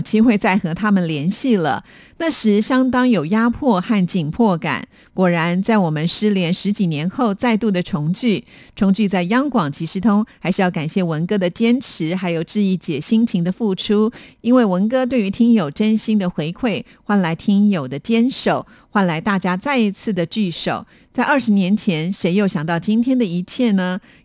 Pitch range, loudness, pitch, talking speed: 180-230 Hz, -18 LUFS, 205 Hz, 270 characters per minute